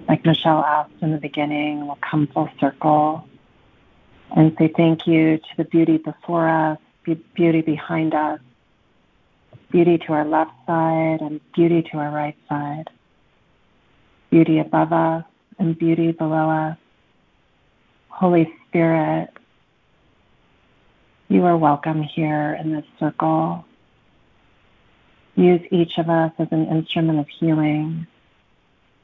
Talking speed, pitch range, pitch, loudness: 120 wpm, 150-165 Hz, 160 Hz, -20 LUFS